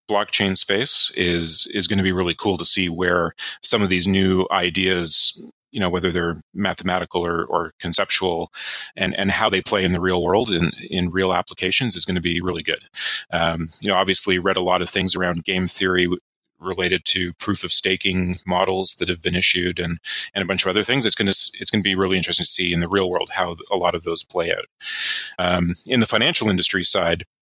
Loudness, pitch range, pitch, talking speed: -19 LUFS, 90-95 Hz, 95 Hz, 220 wpm